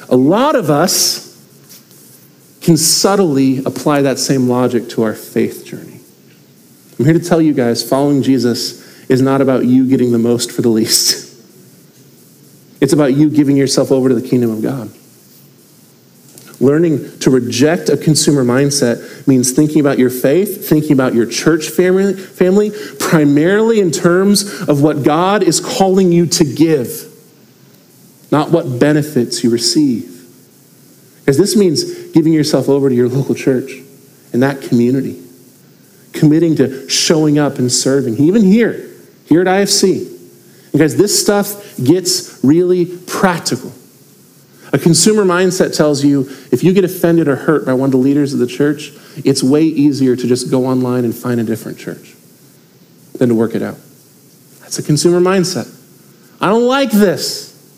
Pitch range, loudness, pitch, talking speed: 130-175 Hz, -13 LUFS, 145 Hz, 155 wpm